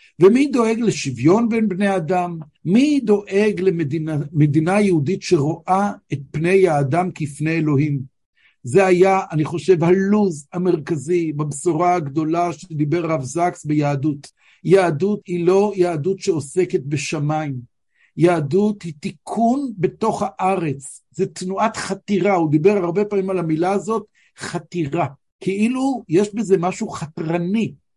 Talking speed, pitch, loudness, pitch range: 120 wpm, 180 Hz, -19 LUFS, 160-195 Hz